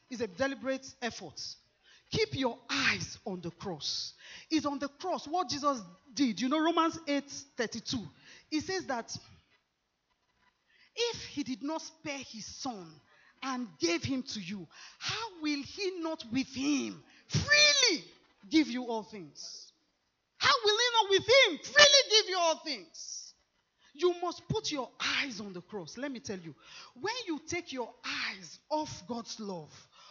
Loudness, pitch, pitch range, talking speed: -30 LUFS, 275 Hz, 225-325 Hz, 155 wpm